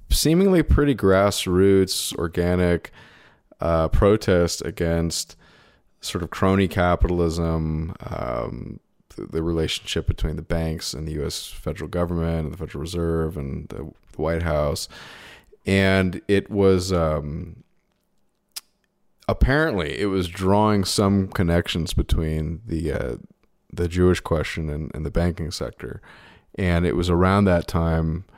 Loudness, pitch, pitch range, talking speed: -22 LUFS, 85 Hz, 80-95 Hz, 125 wpm